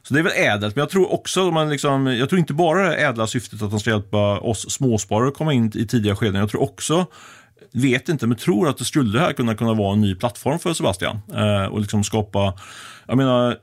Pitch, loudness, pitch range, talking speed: 120 Hz, -20 LUFS, 105-145 Hz, 240 wpm